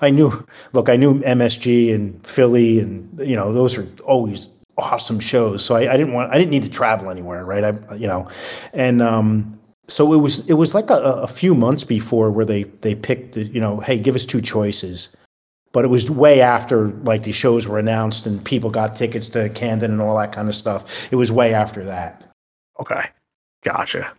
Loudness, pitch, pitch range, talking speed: -18 LUFS, 115 Hz, 105-125 Hz, 210 wpm